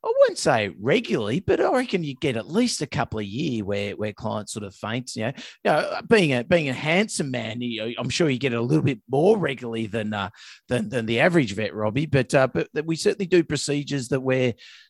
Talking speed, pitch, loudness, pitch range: 240 wpm, 135 Hz, -24 LUFS, 115-165 Hz